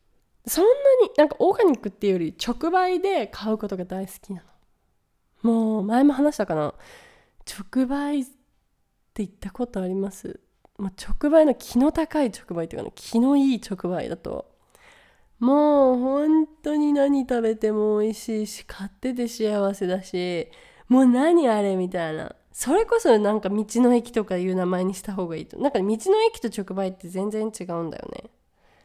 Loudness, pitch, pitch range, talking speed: -23 LUFS, 220 Hz, 190-275 Hz, 320 characters per minute